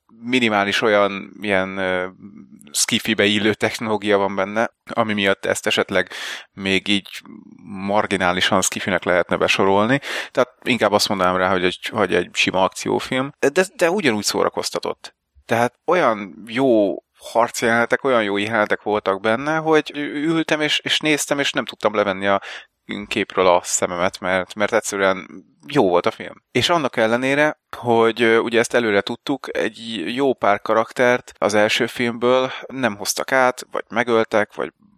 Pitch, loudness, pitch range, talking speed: 110 Hz, -19 LUFS, 100-125 Hz, 145 wpm